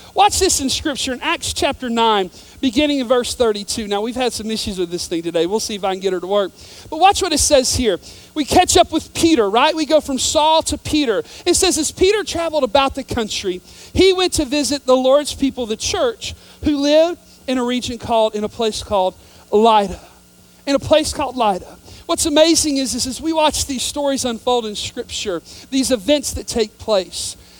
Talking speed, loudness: 215 wpm, -17 LUFS